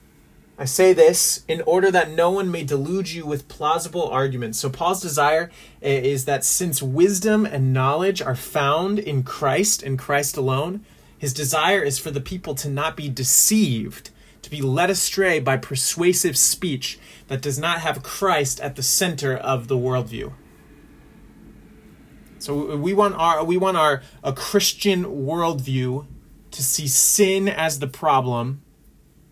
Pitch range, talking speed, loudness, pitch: 135-180 Hz, 150 wpm, -20 LUFS, 145 Hz